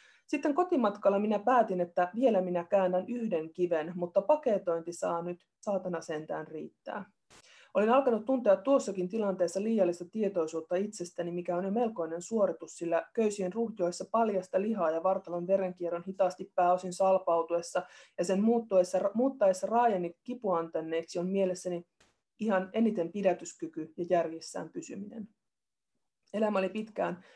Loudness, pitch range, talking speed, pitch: -31 LUFS, 175-220 Hz, 125 wpm, 185 Hz